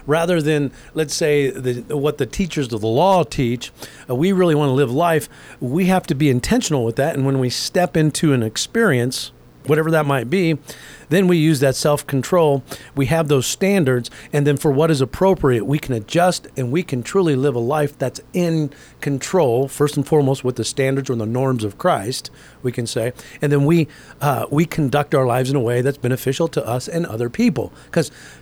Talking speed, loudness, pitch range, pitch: 205 wpm, -19 LUFS, 130-160 Hz, 145 Hz